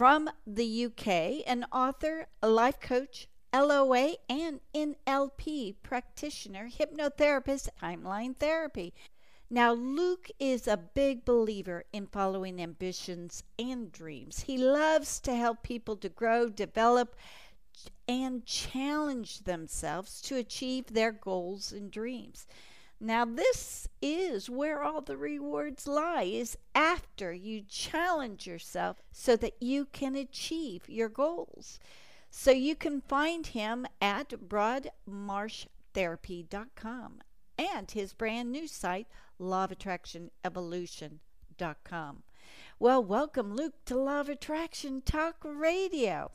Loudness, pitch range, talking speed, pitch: -32 LUFS, 200-285 Hz, 110 wpm, 245 Hz